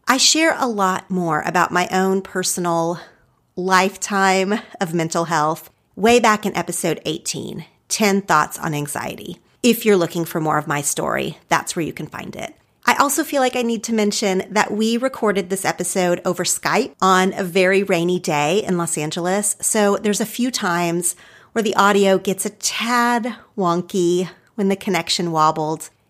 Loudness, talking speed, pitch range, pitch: -19 LUFS, 170 wpm, 175-210 Hz, 190 Hz